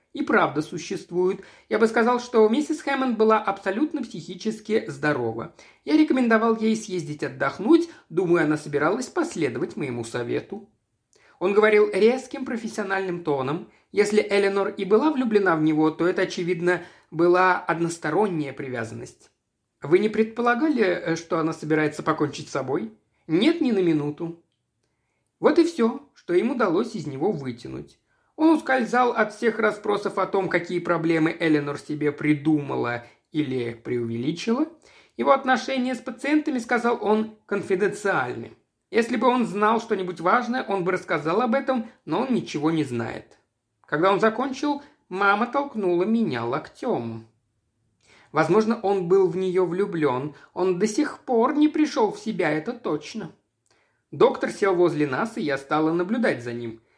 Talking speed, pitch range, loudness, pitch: 140 wpm, 160-240 Hz, -23 LUFS, 195 Hz